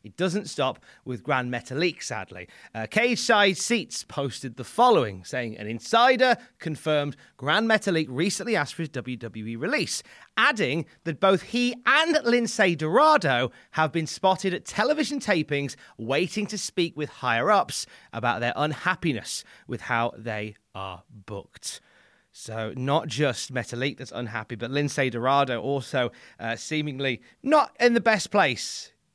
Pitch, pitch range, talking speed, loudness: 145 Hz, 120-195 Hz, 145 wpm, -25 LUFS